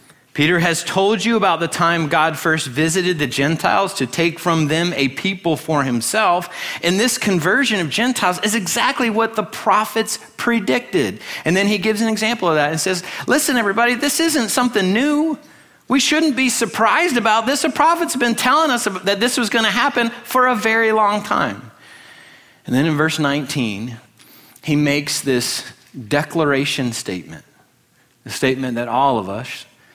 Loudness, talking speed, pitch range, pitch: -17 LUFS, 170 wpm, 150-235 Hz, 190 Hz